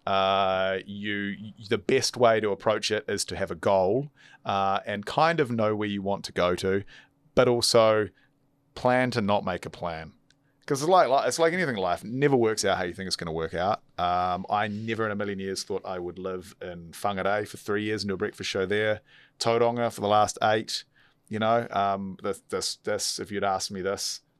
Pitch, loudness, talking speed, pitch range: 105 Hz, -26 LUFS, 220 wpm, 95-115 Hz